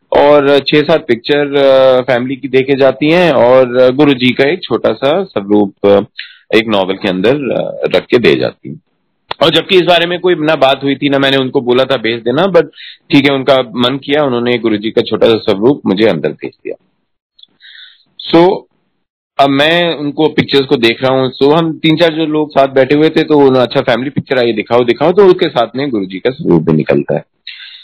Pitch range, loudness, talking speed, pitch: 125-155 Hz, -10 LUFS, 215 wpm, 140 Hz